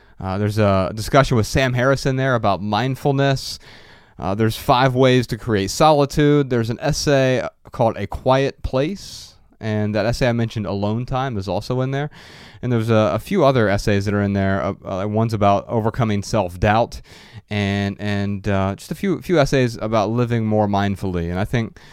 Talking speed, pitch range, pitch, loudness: 185 wpm, 100-130 Hz, 110 Hz, -19 LUFS